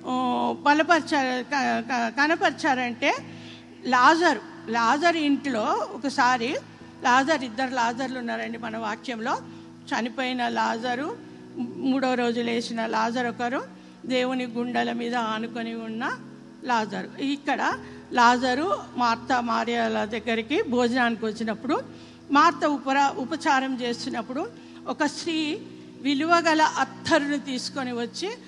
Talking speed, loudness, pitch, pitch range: 85 wpm, -25 LUFS, 255 Hz, 235-285 Hz